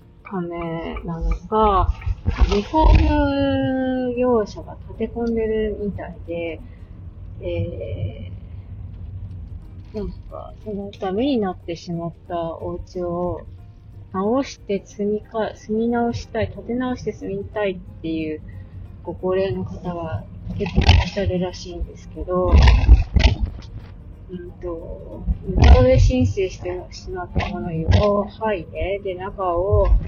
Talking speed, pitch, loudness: 220 characters per minute, 125 Hz, -22 LUFS